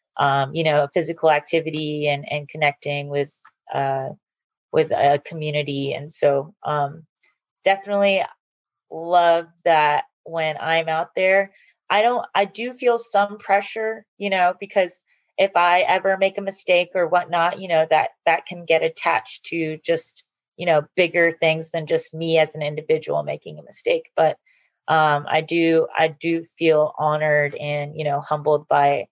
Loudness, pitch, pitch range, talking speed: -21 LUFS, 165 Hz, 150-190 Hz, 155 wpm